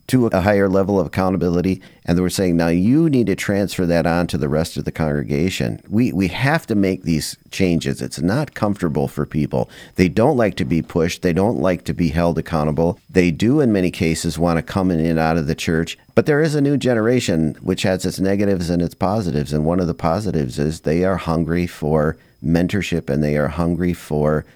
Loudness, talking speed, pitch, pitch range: -19 LUFS, 220 wpm, 85 Hz, 80-95 Hz